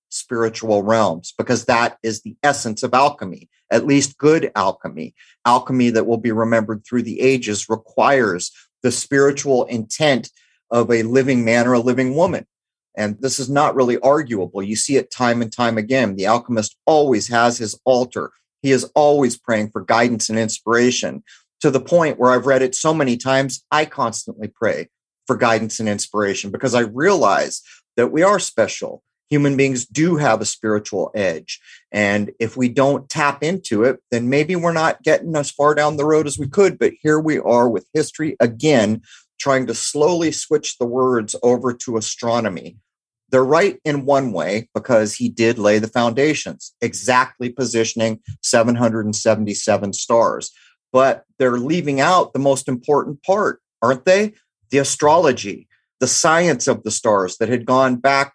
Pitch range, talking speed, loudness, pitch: 115-140 Hz, 170 wpm, -18 LUFS, 125 Hz